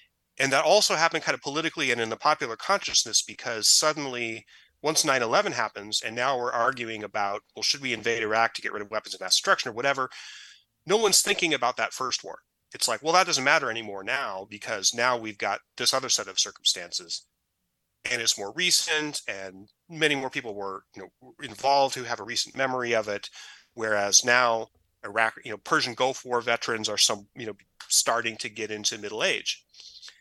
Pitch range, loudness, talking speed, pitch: 105-140 Hz, -25 LUFS, 195 wpm, 120 Hz